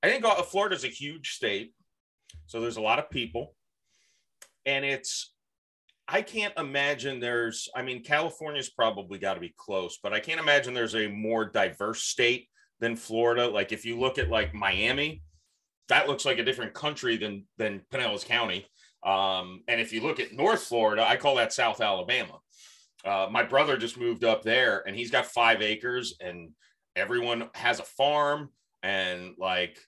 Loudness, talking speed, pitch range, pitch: -28 LUFS, 175 wpm, 105-135 Hz, 115 Hz